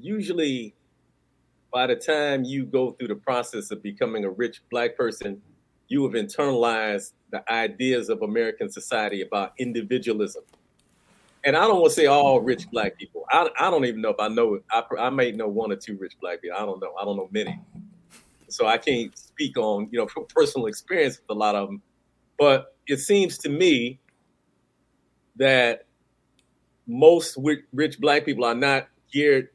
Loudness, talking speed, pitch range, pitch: -23 LUFS, 180 wpm, 120-200 Hz, 140 Hz